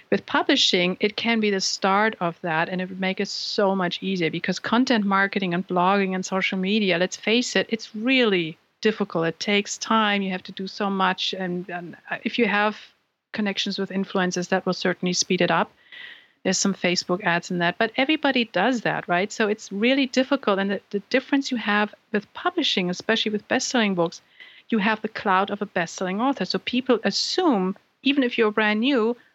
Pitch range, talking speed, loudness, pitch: 185-230 Hz, 200 wpm, -23 LUFS, 200 Hz